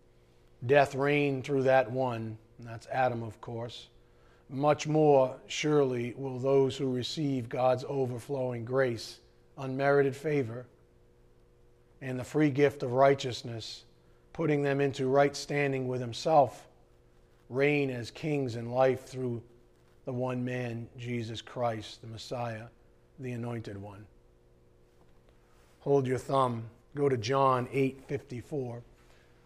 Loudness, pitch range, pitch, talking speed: -30 LUFS, 100-135 Hz, 125 Hz, 120 wpm